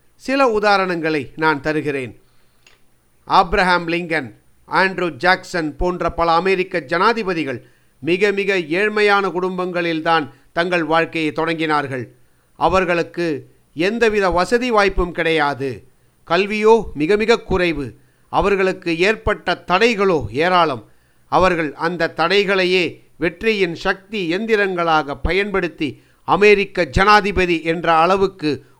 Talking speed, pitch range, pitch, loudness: 90 wpm, 160-195 Hz, 175 Hz, -17 LUFS